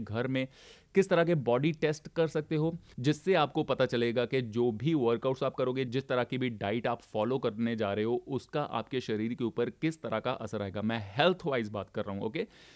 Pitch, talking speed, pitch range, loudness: 125 Hz, 225 wpm, 115-150 Hz, -31 LUFS